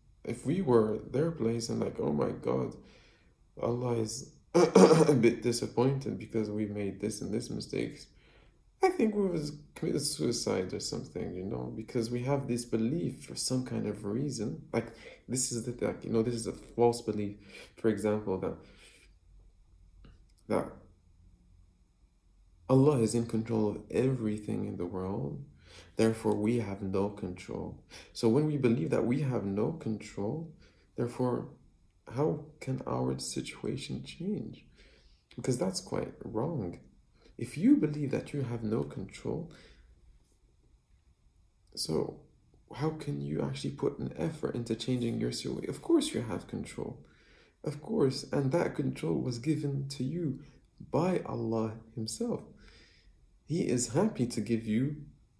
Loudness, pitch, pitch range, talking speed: -32 LUFS, 110 Hz, 95-125 Hz, 145 wpm